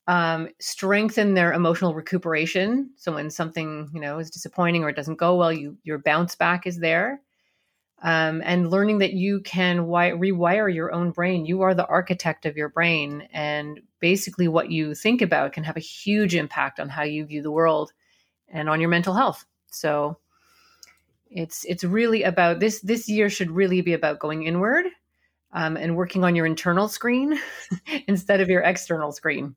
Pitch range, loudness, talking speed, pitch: 160-195 Hz, -23 LUFS, 180 wpm, 175 Hz